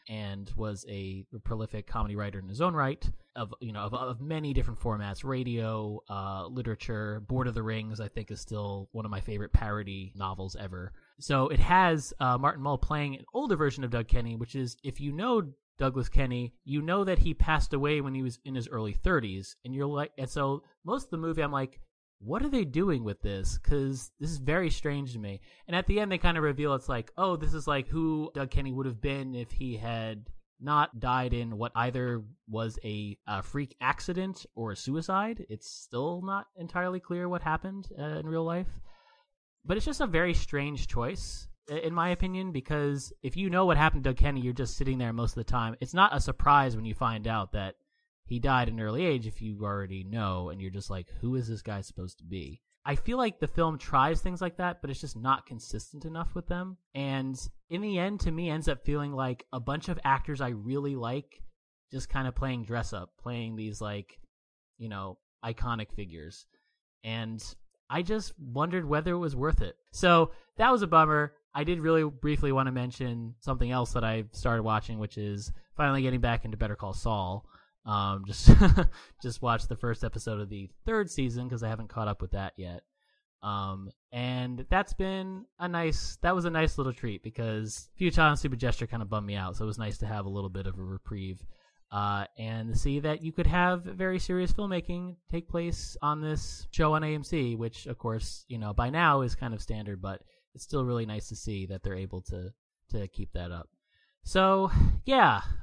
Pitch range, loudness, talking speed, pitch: 110-155 Hz, -31 LUFS, 215 wpm, 125 Hz